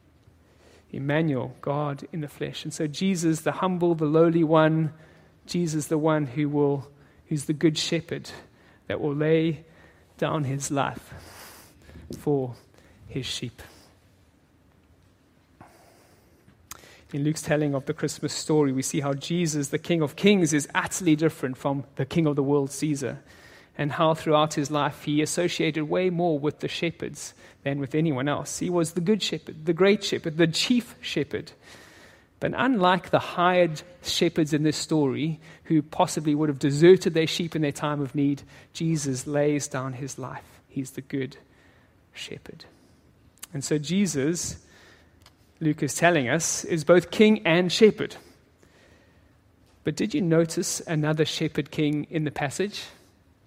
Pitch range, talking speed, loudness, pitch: 140-165 Hz, 150 wpm, -25 LUFS, 150 Hz